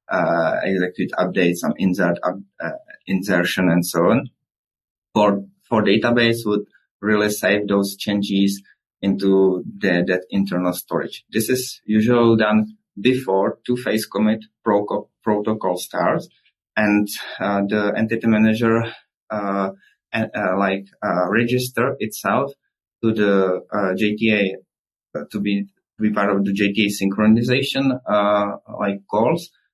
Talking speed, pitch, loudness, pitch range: 125 wpm, 105 Hz, -20 LUFS, 95-110 Hz